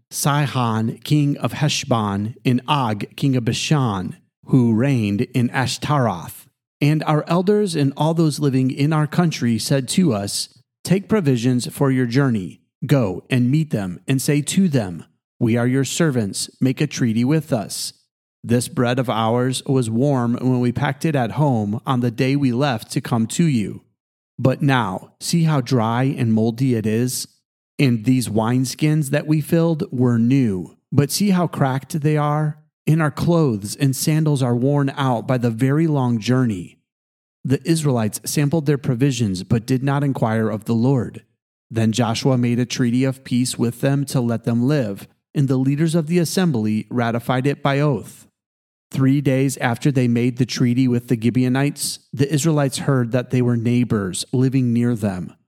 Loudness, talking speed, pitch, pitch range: -19 LUFS, 175 wpm, 130 Hz, 120-145 Hz